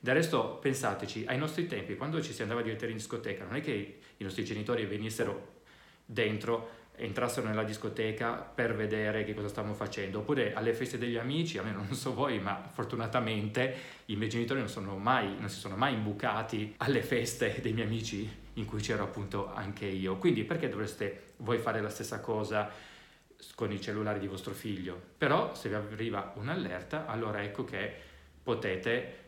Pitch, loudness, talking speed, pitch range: 110 Hz, -34 LUFS, 180 wpm, 105-120 Hz